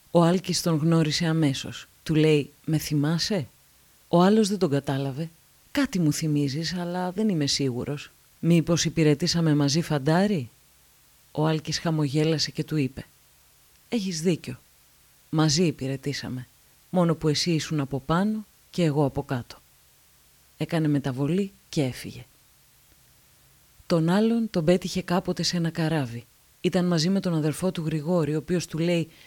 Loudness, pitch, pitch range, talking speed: -25 LUFS, 160 Hz, 145-175 Hz, 135 wpm